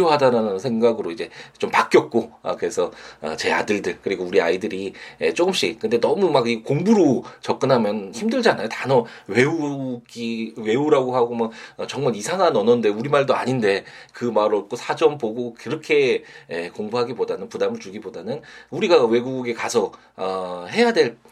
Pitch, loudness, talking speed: 145 Hz, -21 LUFS, 330 characters per minute